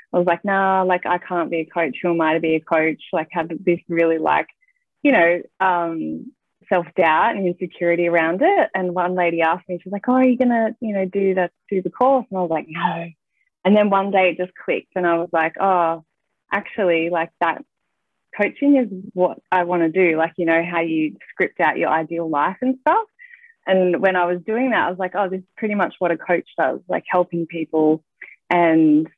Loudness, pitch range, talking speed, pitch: -20 LUFS, 165-195 Hz, 225 wpm, 180 Hz